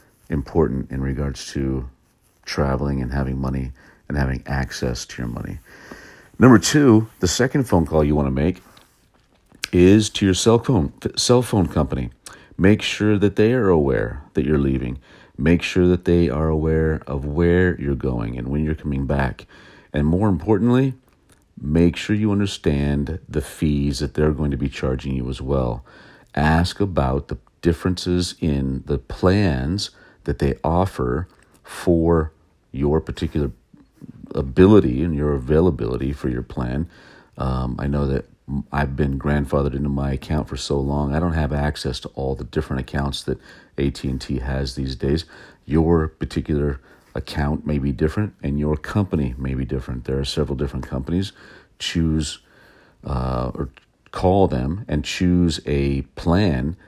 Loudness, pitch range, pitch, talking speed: -21 LUFS, 65-90 Hz, 75 Hz, 155 wpm